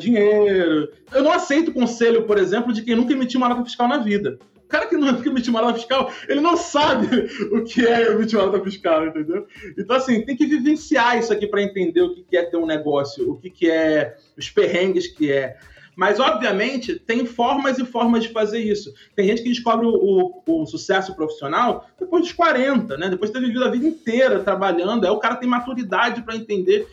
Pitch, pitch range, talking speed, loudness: 235 Hz, 200-285 Hz, 210 wpm, -20 LUFS